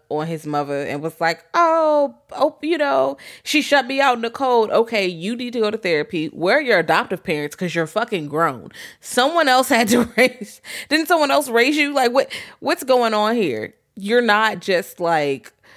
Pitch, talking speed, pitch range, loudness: 225 Hz, 200 wpm, 170-275 Hz, -19 LUFS